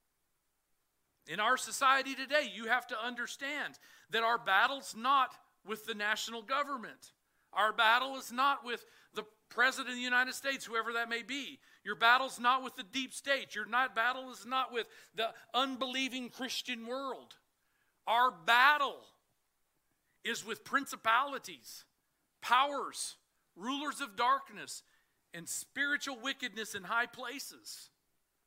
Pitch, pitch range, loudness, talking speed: 250 Hz, 230-265 Hz, -33 LUFS, 130 wpm